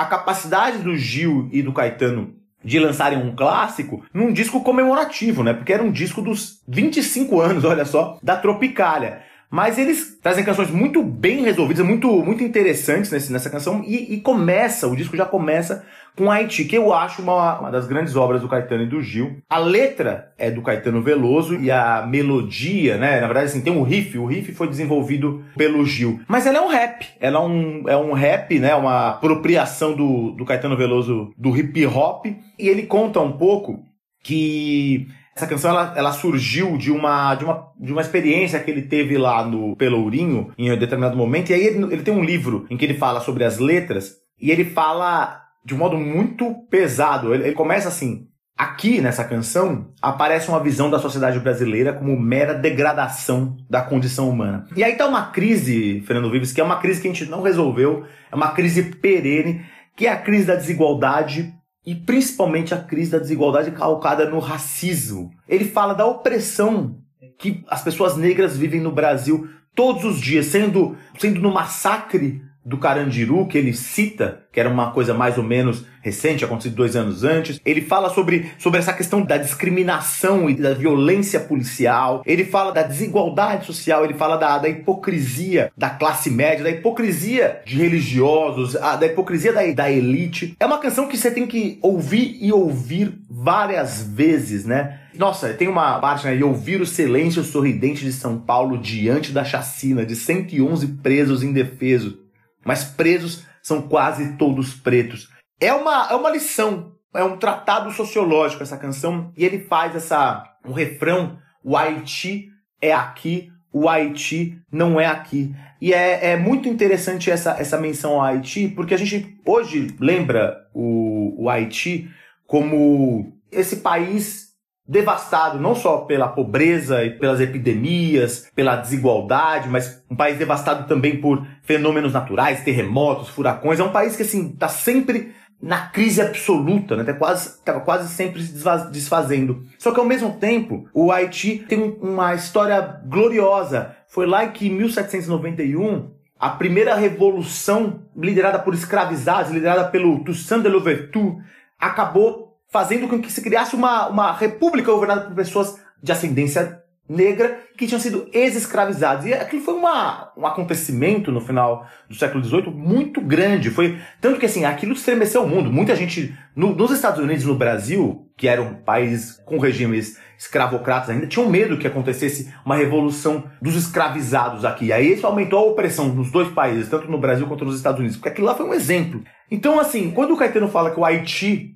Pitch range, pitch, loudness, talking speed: 140-195 Hz, 160 Hz, -19 LUFS, 175 wpm